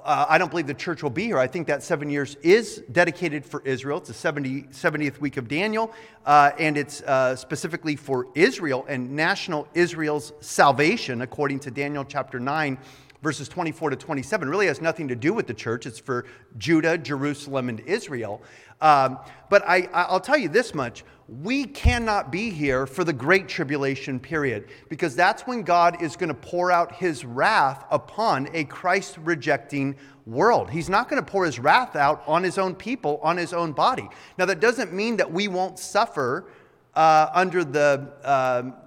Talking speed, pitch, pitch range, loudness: 185 wpm, 155 Hz, 140-180 Hz, -23 LUFS